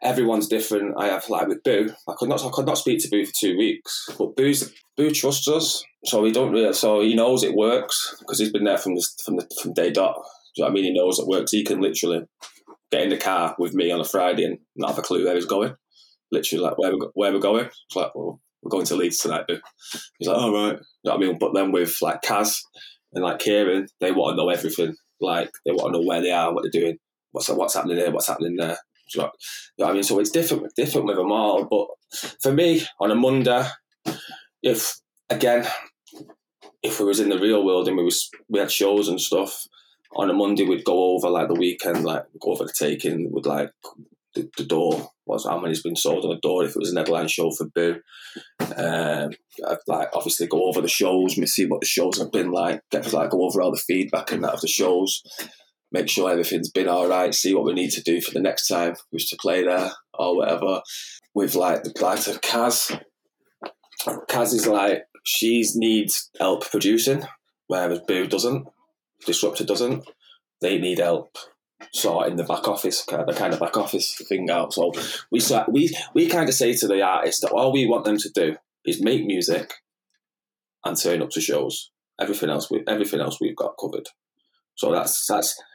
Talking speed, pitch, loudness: 225 wpm, 105 Hz, -22 LUFS